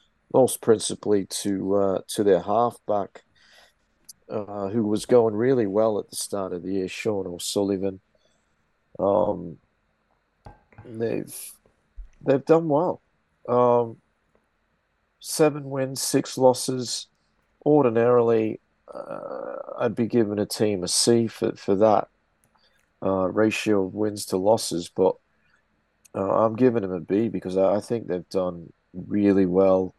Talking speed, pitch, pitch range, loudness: 130 wpm, 105 Hz, 95-120 Hz, -23 LUFS